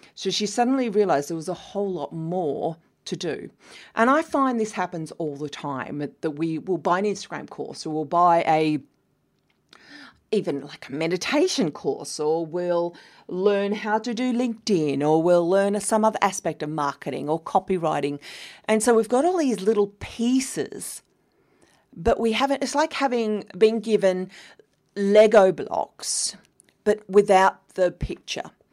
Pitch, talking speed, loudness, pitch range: 195 Hz, 155 wpm, -23 LUFS, 165-220 Hz